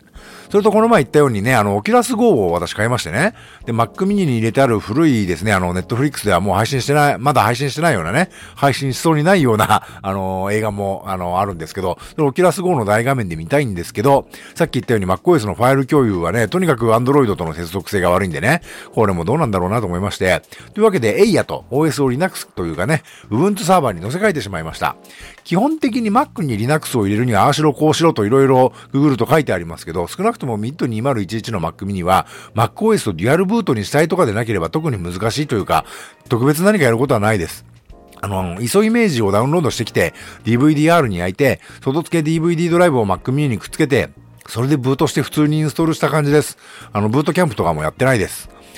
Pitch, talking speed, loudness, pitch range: 125 Hz, 535 characters per minute, -16 LUFS, 105-160 Hz